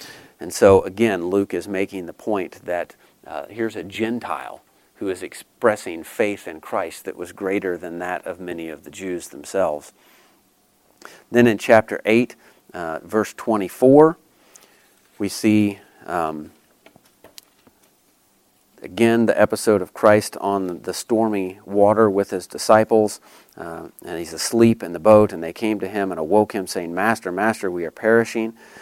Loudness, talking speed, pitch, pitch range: -20 LUFS, 150 wpm, 105 Hz, 95-115 Hz